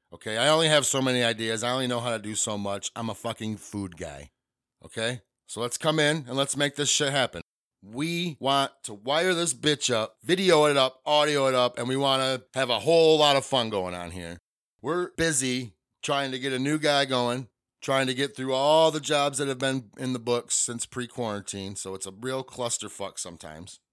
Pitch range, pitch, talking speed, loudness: 110-145 Hz, 130 Hz, 220 wpm, -25 LUFS